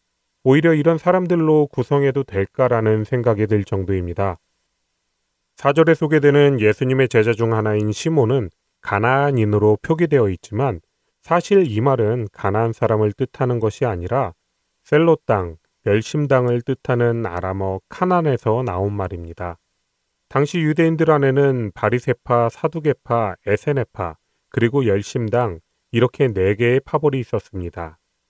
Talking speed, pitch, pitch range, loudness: 300 characters per minute, 120 Hz, 105-140 Hz, -19 LUFS